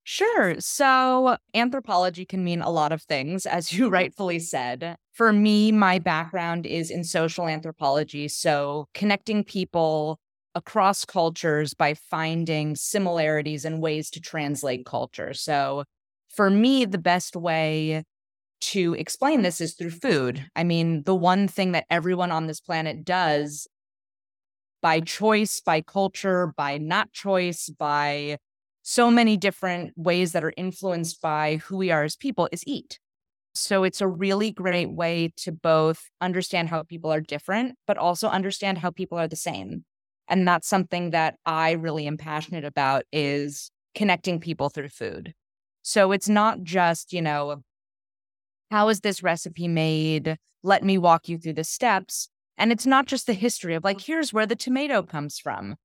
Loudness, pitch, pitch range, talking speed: -24 LUFS, 170 Hz, 155-195 Hz, 160 wpm